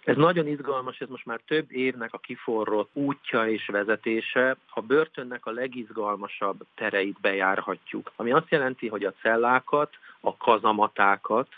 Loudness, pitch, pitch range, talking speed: -26 LUFS, 120 Hz, 110-130 Hz, 140 wpm